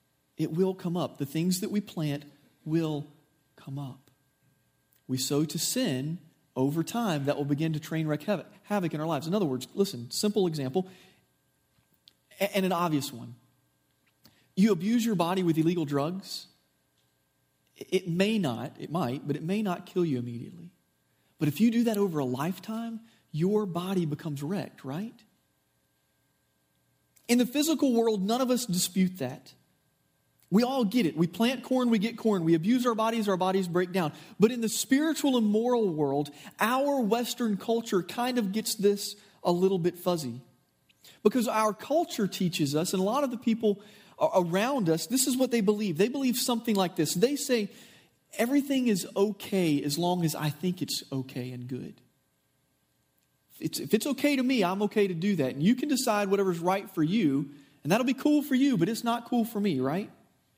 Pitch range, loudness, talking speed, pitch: 150-225 Hz, -28 LUFS, 180 wpm, 190 Hz